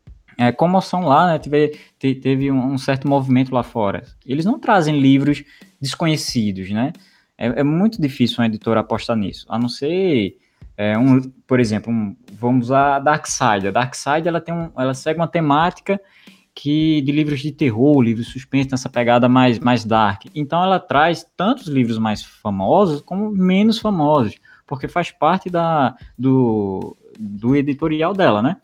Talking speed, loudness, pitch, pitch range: 160 wpm, -18 LUFS, 135 Hz, 120-160 Hz